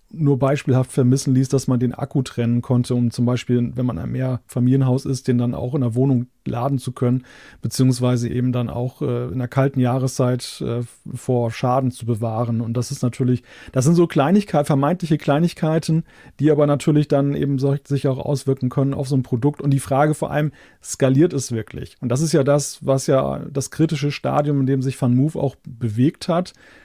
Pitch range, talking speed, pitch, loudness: 125-145 Hz, 200 wpm, 135 Hz, -20 LUFS